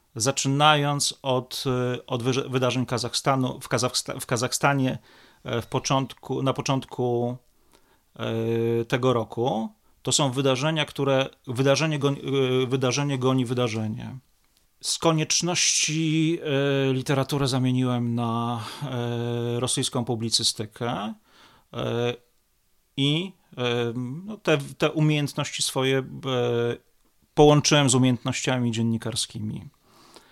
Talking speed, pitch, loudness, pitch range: 75 wpm, 130 Hz, -24 LUFS, 120-140 Hz